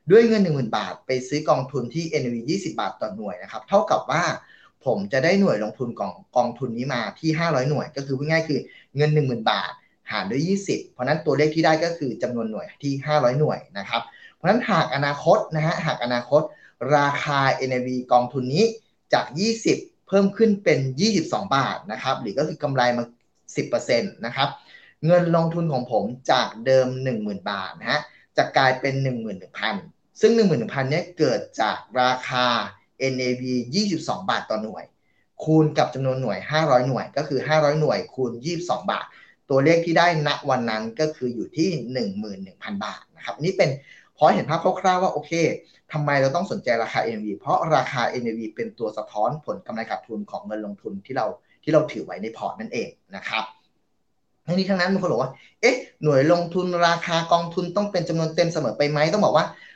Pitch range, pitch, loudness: 125-170 Hz, 150 Hz, -23 LUFS